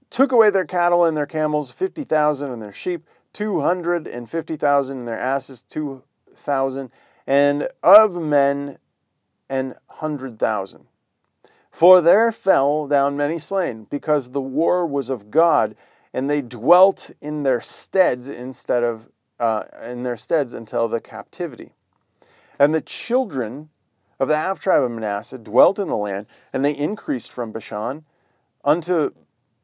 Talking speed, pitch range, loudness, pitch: 150 wpm, 125-165 Hz, -21 LUFS, 140 Hz